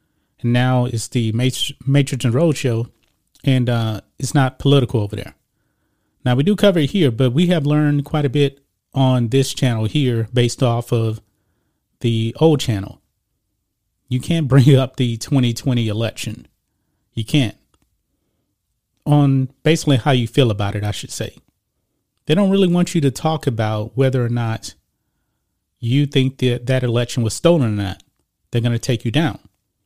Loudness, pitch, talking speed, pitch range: -18 LUFS, 125 Hz, 165 wpm, 110-140 Hz